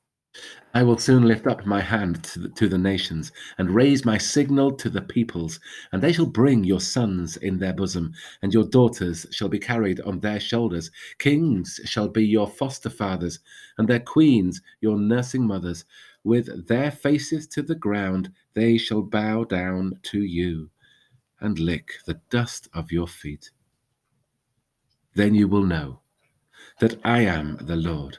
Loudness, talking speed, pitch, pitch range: -23 LUFS, 160 wpm, 110 Hz, 95-120 Hz